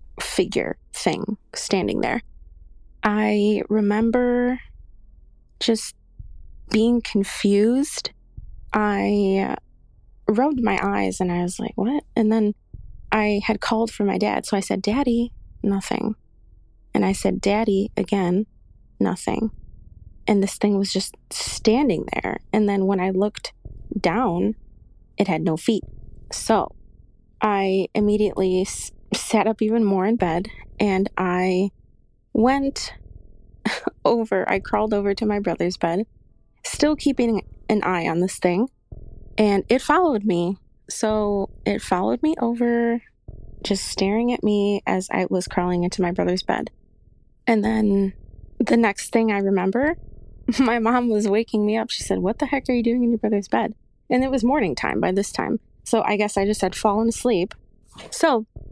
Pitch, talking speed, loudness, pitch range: 210 Hz, 145 wpm, -22 LUFS, 190-230 Hz